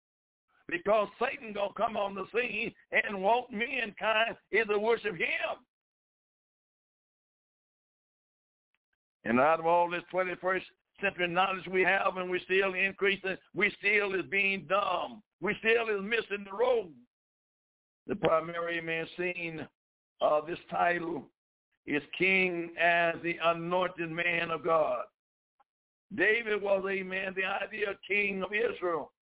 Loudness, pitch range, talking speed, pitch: -30 LUFS, 175-210 Hz, 130 wpm, 190 Hz